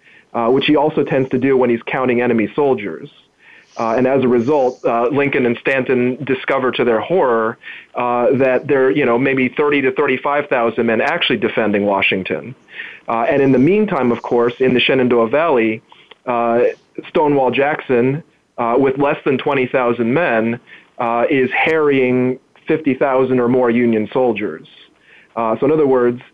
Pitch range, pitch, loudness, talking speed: 120-135 Hz, 125 Hz, -16 LUFS, 170 wpm